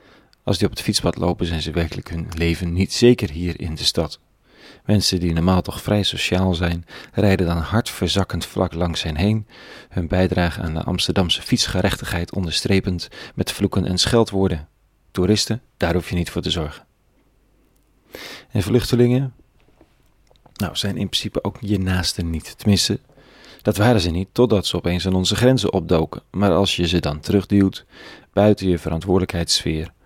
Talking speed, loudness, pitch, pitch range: 165 wpm, -20 LUFS, 95 Hz, 85-105 Hz